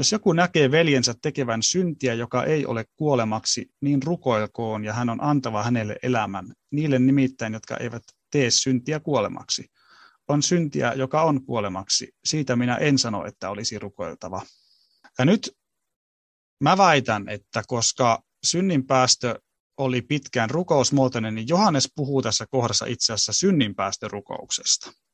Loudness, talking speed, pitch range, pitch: -23 LUFS, 130 wpm, 110-145 Hz, 125 Hz